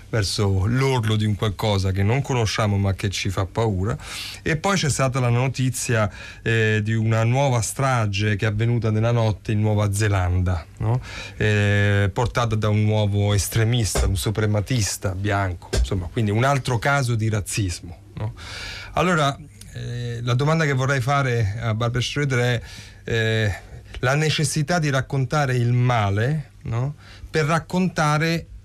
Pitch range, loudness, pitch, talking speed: 100-130 Hz, -22 LUFS, 110 Hz, 150 wpm